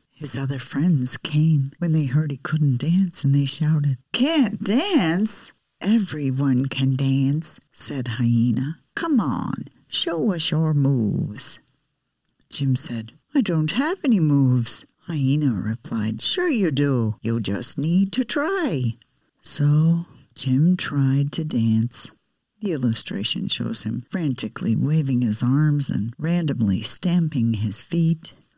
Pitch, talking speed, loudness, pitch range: 140 Hz, 130 wpm, -21 LUFS, 125-165 Hz